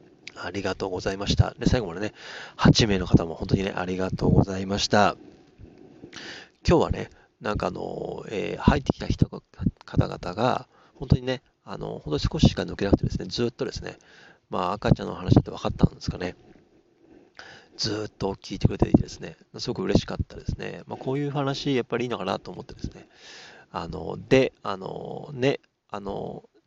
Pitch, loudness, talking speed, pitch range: 115 Hz, -26 LUFS, 360 characters per minute, 95-130 Hz